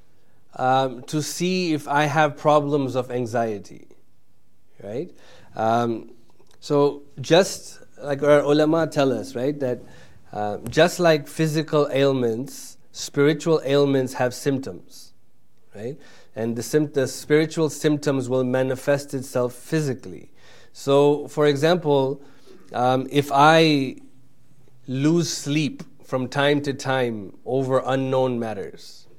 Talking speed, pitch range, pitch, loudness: 115 wpm, 130-150 Hz, 140 Hz, -22 LUFS